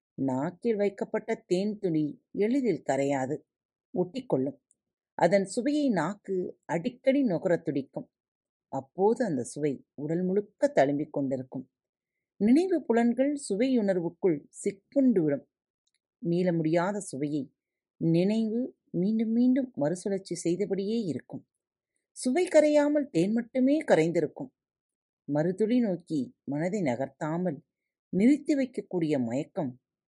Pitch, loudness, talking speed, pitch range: 195 Hz, -28 LUFS, 90 wpm, 160-245 Hz